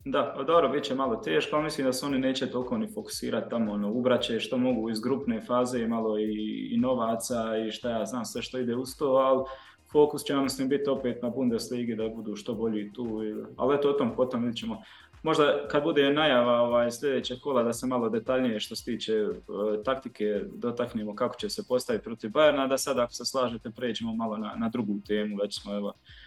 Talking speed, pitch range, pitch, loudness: 215 wpm, 110-135 Hz, 120 Hz, -28 LUFS